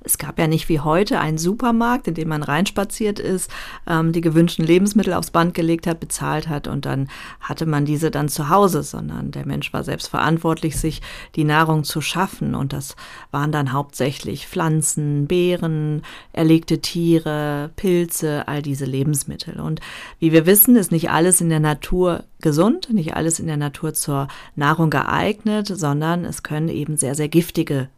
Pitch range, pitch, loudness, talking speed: 145-175 Hz, 160 Hz, -19 LUFS, 170 wpm